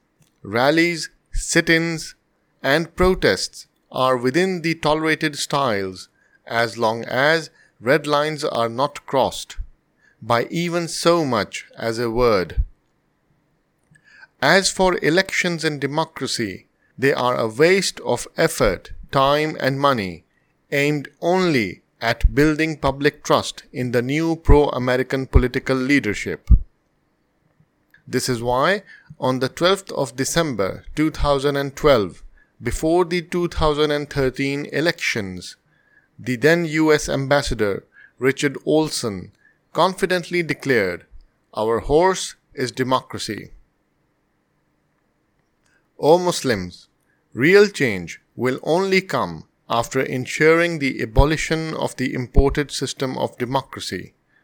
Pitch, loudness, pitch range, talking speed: 145 Hz, -20 LUFS, 130-165 Hz, 105 wpm